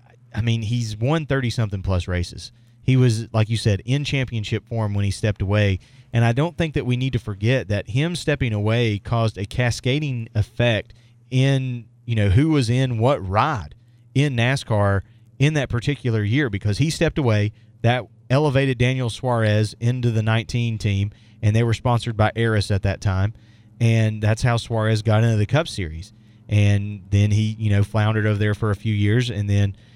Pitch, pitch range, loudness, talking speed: 115 Hz, 105-125 Hz, -21 LUFS, 190 wpm